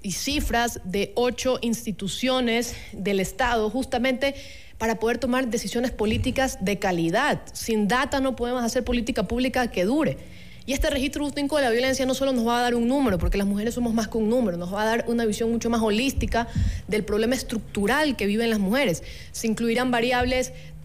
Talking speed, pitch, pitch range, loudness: 190 wpm, 235 Hz, 215-255 Hz, -24 LUFS